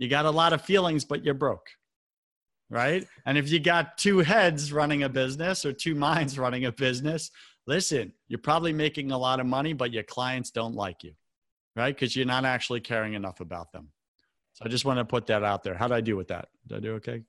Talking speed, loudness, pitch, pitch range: 235 wpm, -27 LUFS, 130 Hz, 115-150 Hz